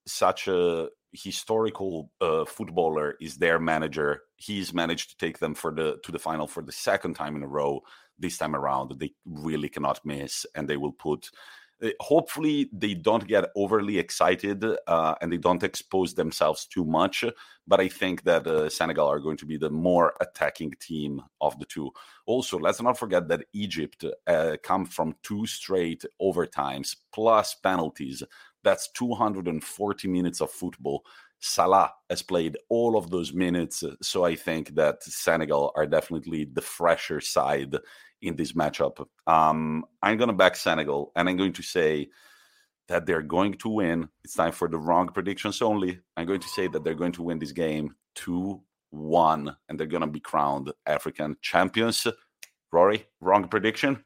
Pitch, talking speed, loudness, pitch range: 85 Hz, 170 wpm, -27 LUFS, 75-100 Hz